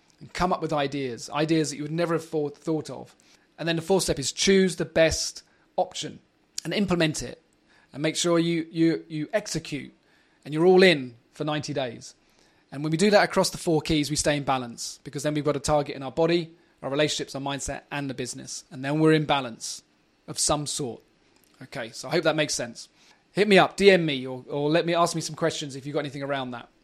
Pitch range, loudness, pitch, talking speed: 145-165 Hz, -25 LUFS, 155 Hz, 230 wpm